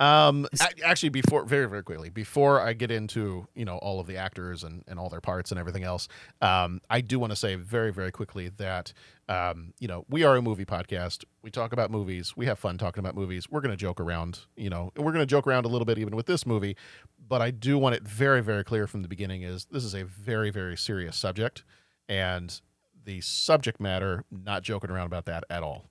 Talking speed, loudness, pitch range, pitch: 235 wpm, -28 LUFS, 90-120 Hz, 100 Hz